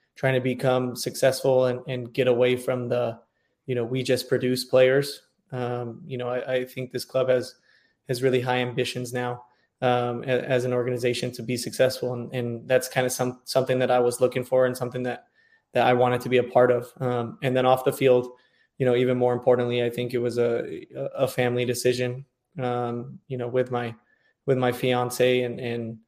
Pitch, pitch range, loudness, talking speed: 125 Hz, 125-130 Hz, -25 LUFS, 205 wpm